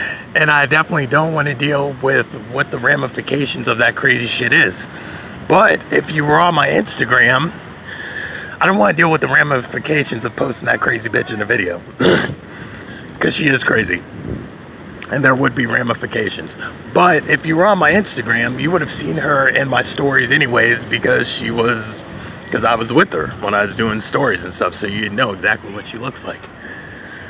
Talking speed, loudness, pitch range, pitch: 200 wpm, -15 LUFS, 130-150 Hz, 140 Hz